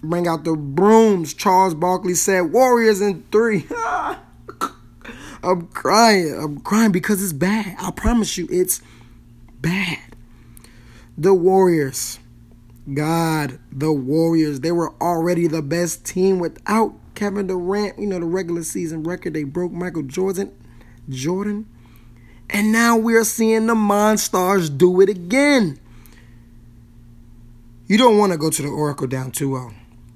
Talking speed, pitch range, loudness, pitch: 135 wpm, 130-195 Hz, -19 LUFS, 170 Hz